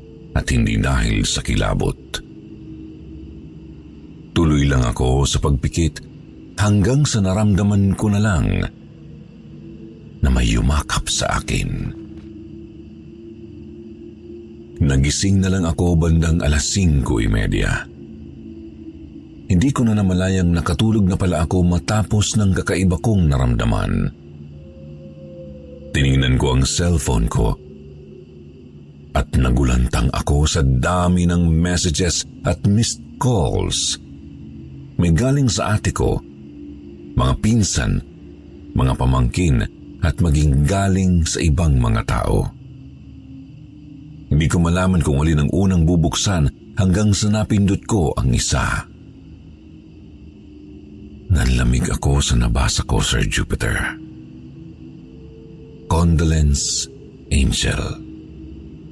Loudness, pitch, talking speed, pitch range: -18 LUFS, 80 Hz, 100 wpm, 70-100 Hz